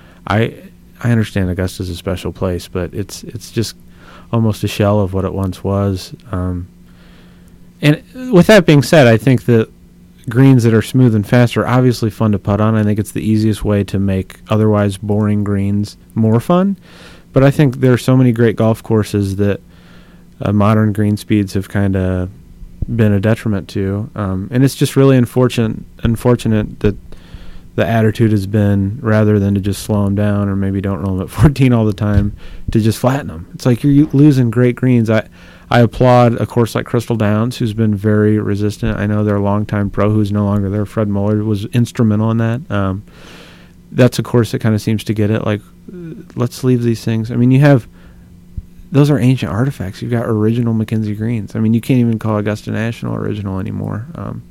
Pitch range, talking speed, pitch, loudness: 100-120 Hz, 200 wpm, 110 Hz, -14 LUFS